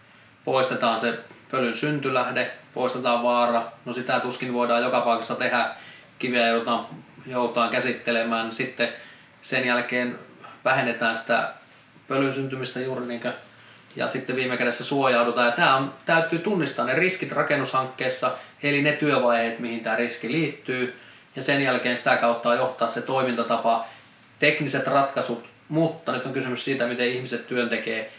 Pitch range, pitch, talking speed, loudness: 120-130 Hz, 125 Hz, 130 wpm, -24 LUFS